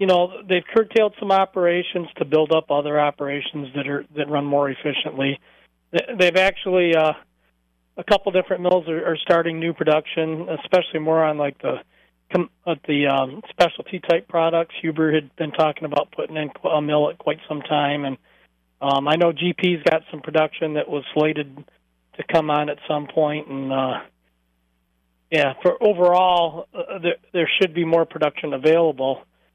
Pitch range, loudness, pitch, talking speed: 145-170 Hz, -21 LUFS, 155 Hz, 170 wpm